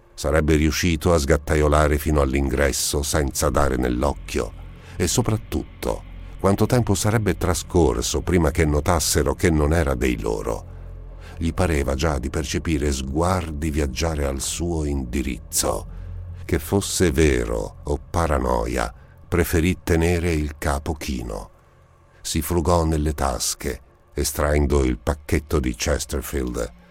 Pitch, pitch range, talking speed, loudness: 80 Hz, 75-85 Hz, 115 wpm, -22 LUFS